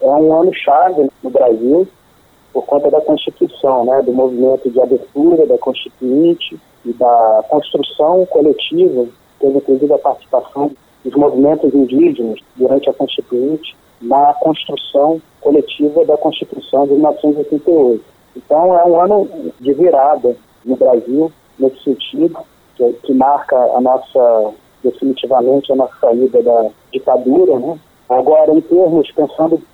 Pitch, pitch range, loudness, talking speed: 145 Hz, 130-175 Hz, -13 LUFS, 130 wpm